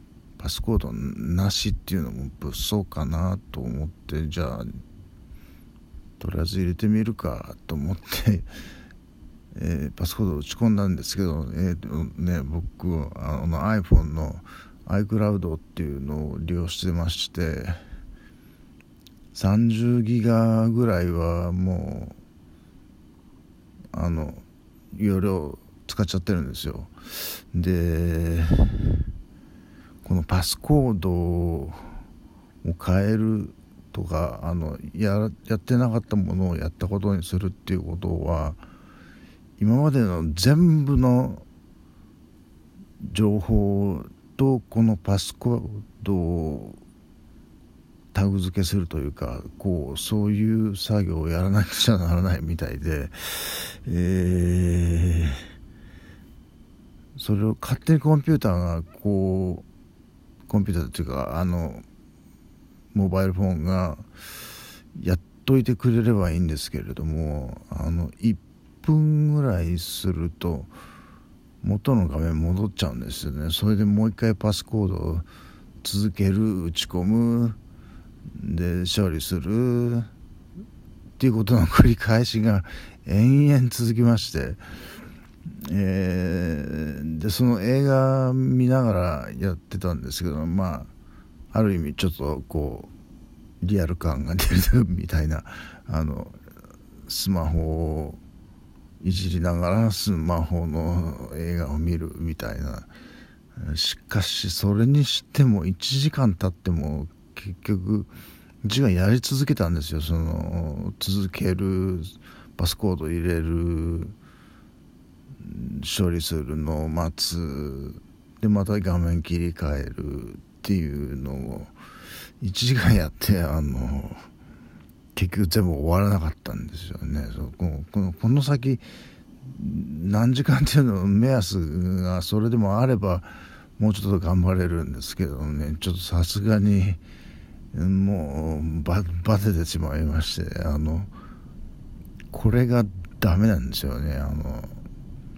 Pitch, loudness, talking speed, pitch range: 90 Hz, -24 LUFS, 230 characters per minute, 80-105 Hz